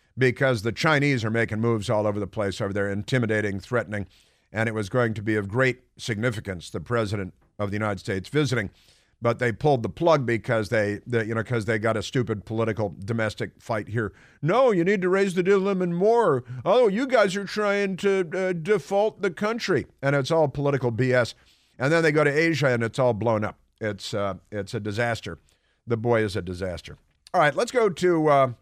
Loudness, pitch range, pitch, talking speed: -24 LUFS, 105-150 Hz, 120 Hz, 210 wpm